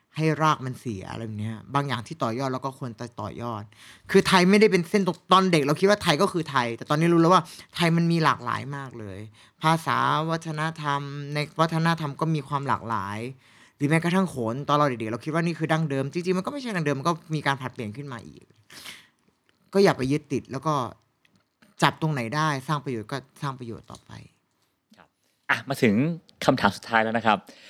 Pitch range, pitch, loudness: 120-165 Hz, 145 Hz, -25 LUFS